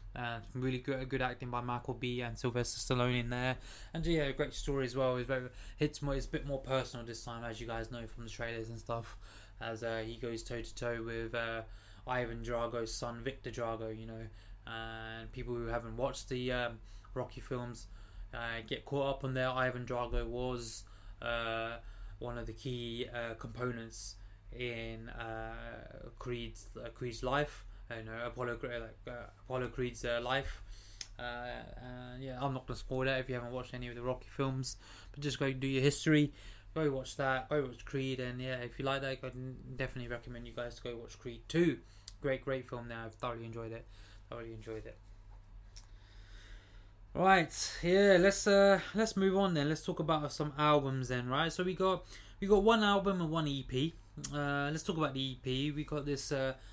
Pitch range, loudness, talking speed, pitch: 115-135 Hz, -36 LUFS, 205 wpm, 120 Hz